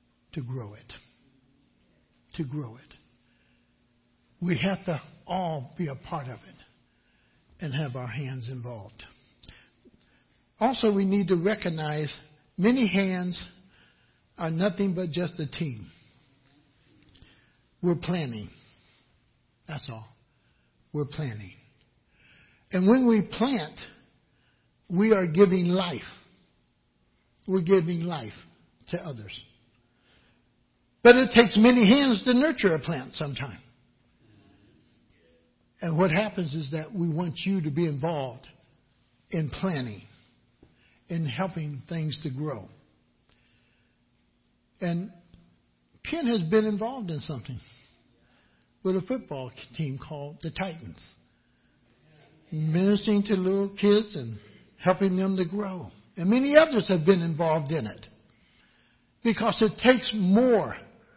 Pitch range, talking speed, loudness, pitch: 130-195 Hz, 115 wpm, -26 LUFS, 160 Hz